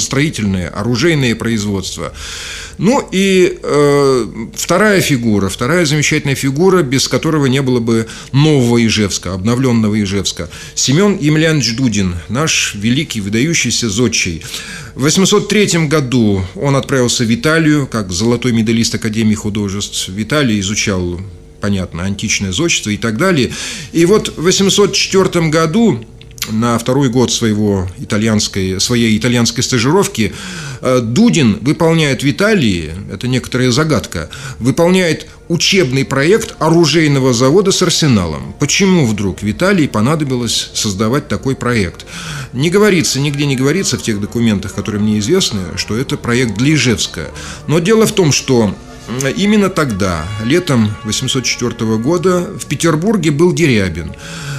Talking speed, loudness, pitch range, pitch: 125 wpm, -13 LUFS, 105-155 Hz, 125 Hz